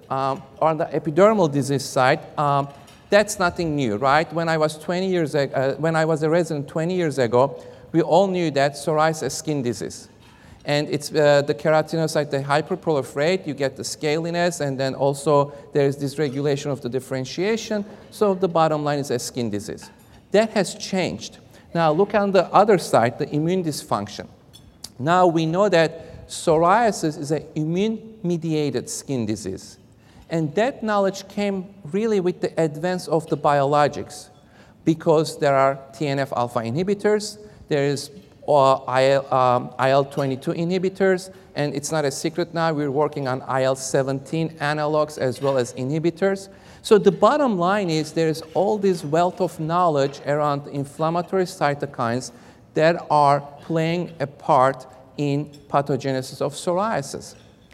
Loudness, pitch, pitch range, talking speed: -22 LUFS, 155 Hz, 140-175 Hz, 150 wpm